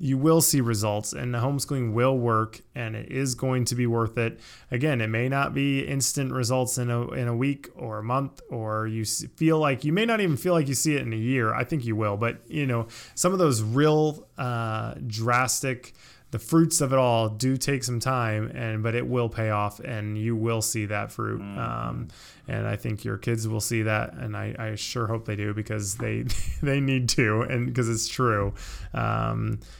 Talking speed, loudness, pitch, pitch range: 220 wpm, -26 LUFS, 120 Hz, 110-135 Hz